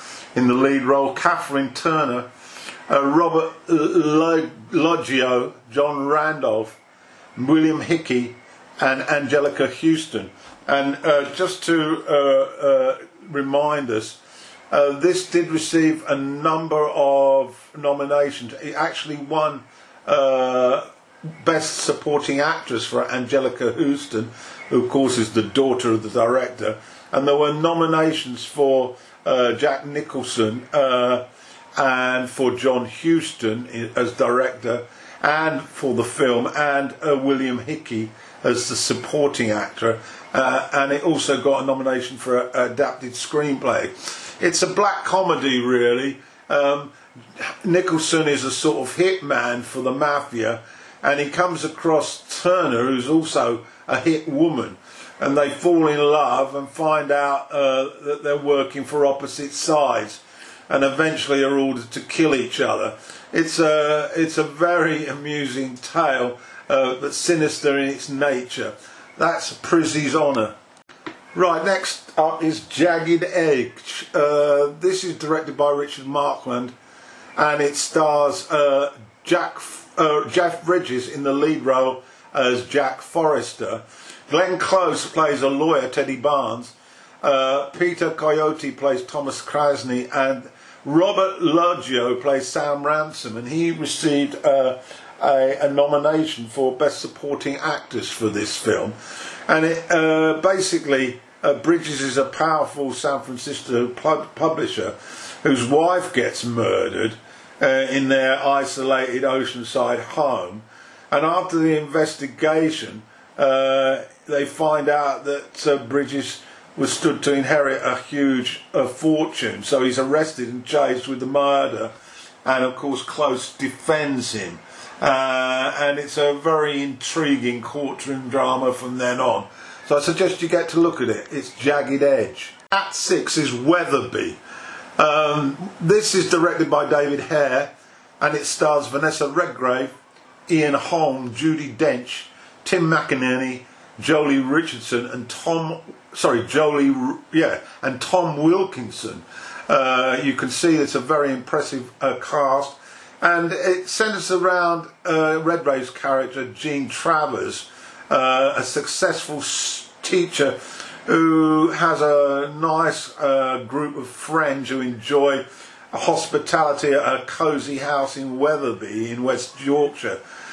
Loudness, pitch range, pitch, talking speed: -20 LUFS, 130-160 Hz, 145 Hz, 130 wpm